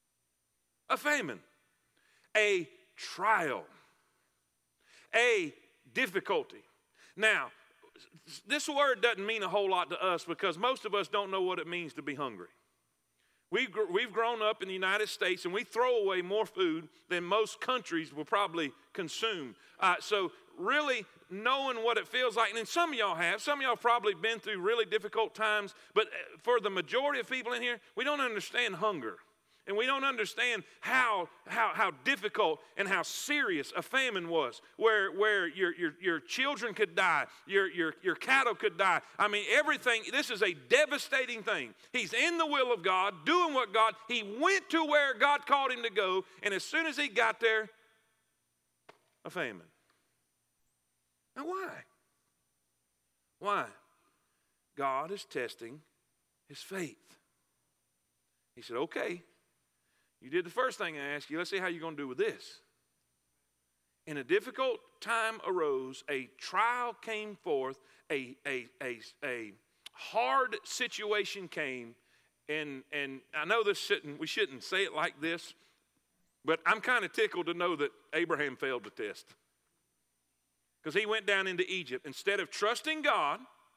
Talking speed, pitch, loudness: 160 wpm, 210 Hz, -32 LUFS